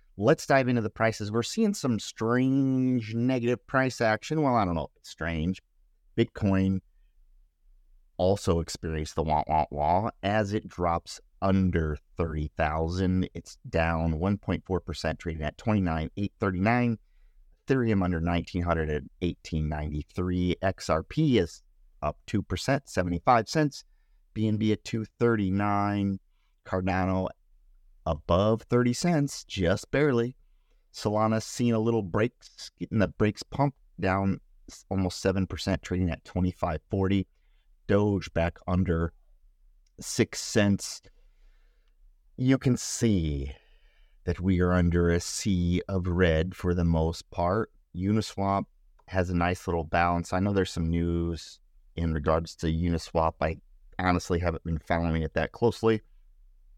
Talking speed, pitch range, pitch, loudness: 135 wpm, 85-110 Hz, 95 Hz, -28 LUFS